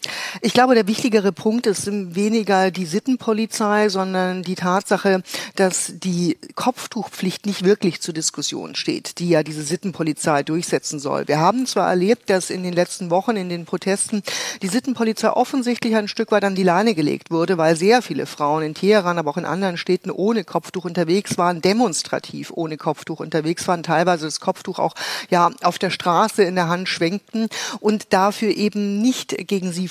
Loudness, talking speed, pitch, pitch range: -20 LUFS, 175 wpm, 190 Hz, 175-215 Hz